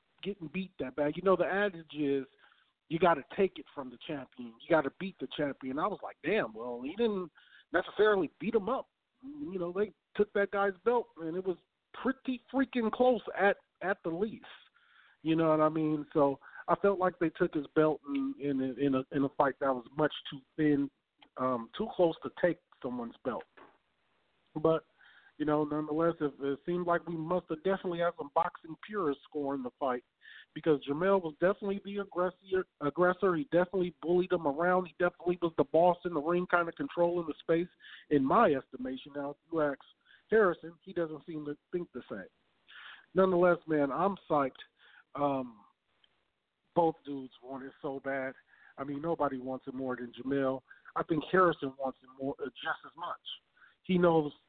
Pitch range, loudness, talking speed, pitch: 140-180 Hz, -32 LUFS, 190 wpm, 160 Hz